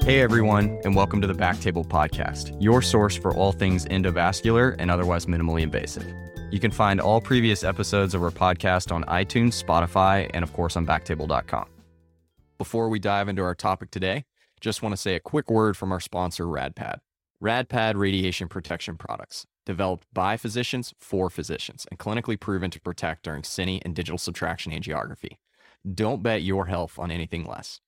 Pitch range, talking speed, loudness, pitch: 85-105 Hz, 170 wpm, -25 LUFS, 95 Hz